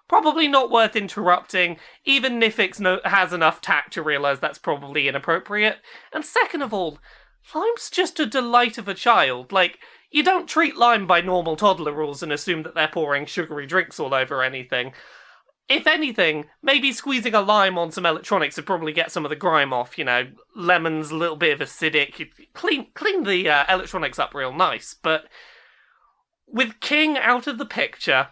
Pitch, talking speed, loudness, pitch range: 185 Hz, 180 wpm, -21 LUFS, 155-245 Hz